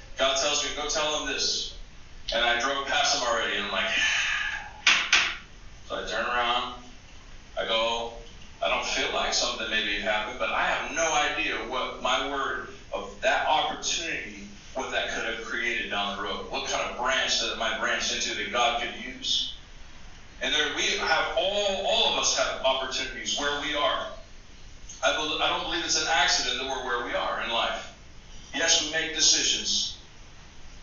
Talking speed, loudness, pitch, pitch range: 180 wpm, -26 LUFS, 120 Hz, 95-145 Hz